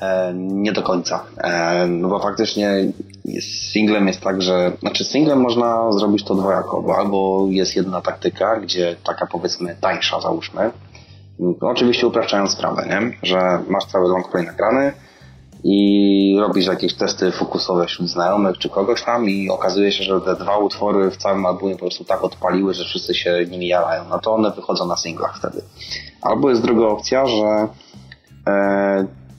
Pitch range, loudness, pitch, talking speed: 90-105 Hz, -18 LUFS, 95 Hz, 165 wpm